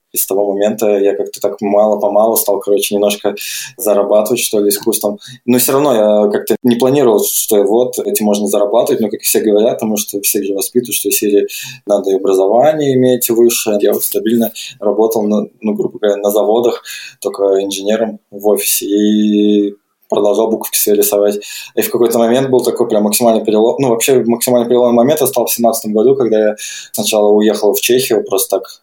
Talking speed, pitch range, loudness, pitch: 185 wpm, 105-120 Hz, -13 LUFS, 105 Hz